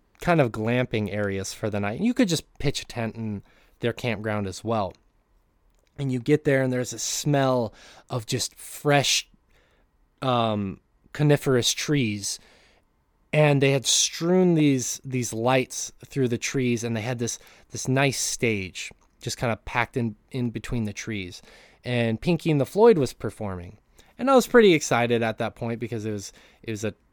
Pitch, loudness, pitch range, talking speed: 120 Hz, -24 LUFS, 110-135 Hz, 175 wpm